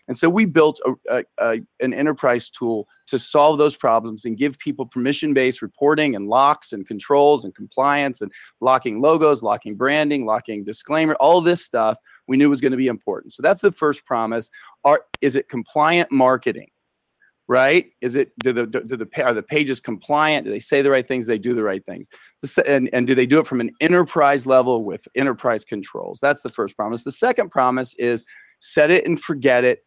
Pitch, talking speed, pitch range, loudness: 135 Hz, 205 wpm, 120-150 Hz, -19 LUFS